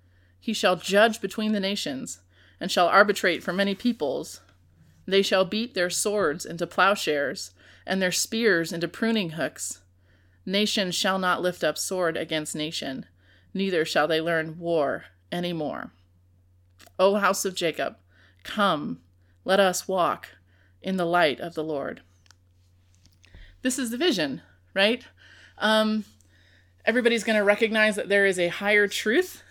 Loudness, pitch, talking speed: -25 LUFS, 170 Hz, 140 wpm